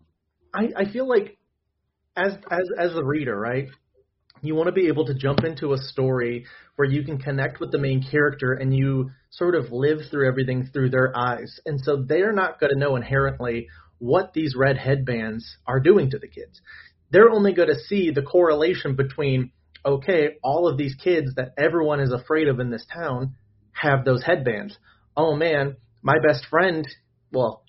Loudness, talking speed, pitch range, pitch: -22 LUFS, 180 wpm, 130-160 Hz, 140 Hz